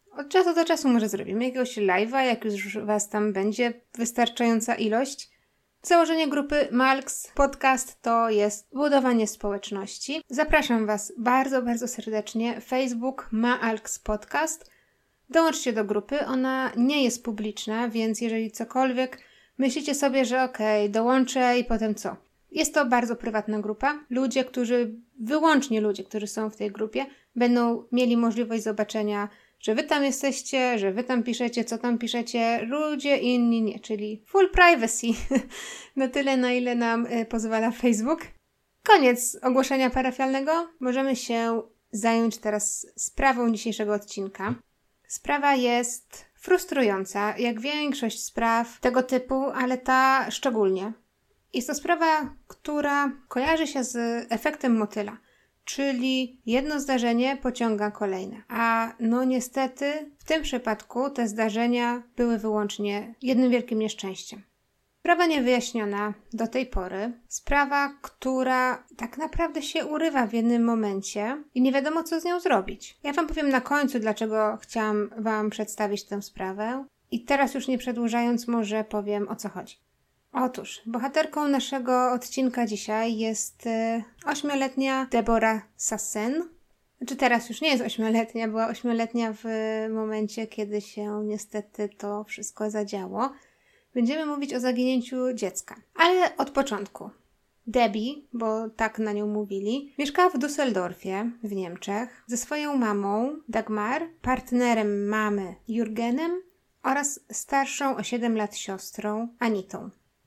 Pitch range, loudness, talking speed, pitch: 220-265 Hz, -26 LUFS, 130 wpm, 240 Hz